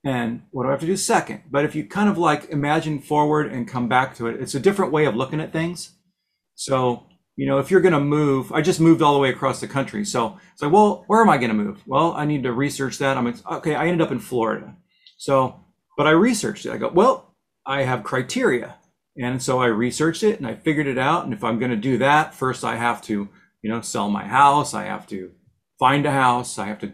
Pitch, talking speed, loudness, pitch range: 140 Hz, 255 wpm, -21 LUFS, 125-155 Hz